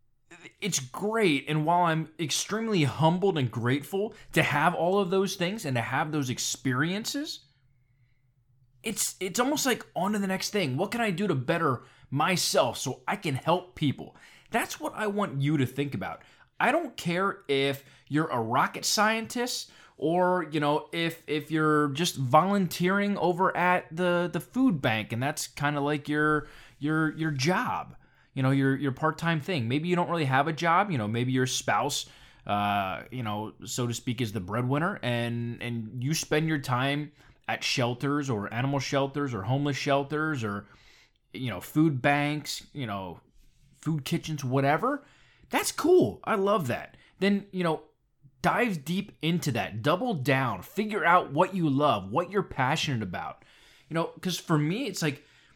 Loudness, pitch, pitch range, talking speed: -28 LUFS, 150 Hz, 130-180 Hz, 175 wpm